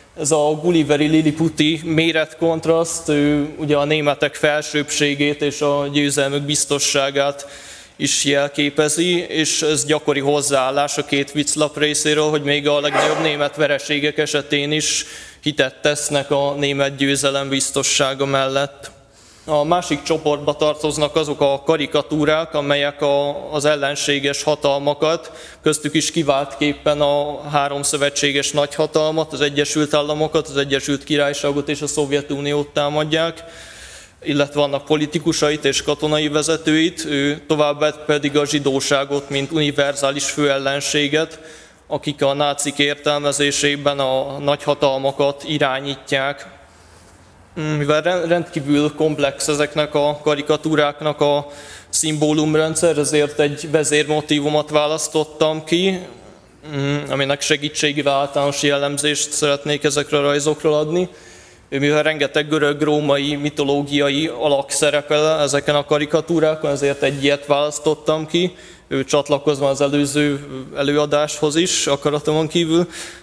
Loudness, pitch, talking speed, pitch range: -18 LUFS, 150 Hz, 105 wpm, 145-155 Hz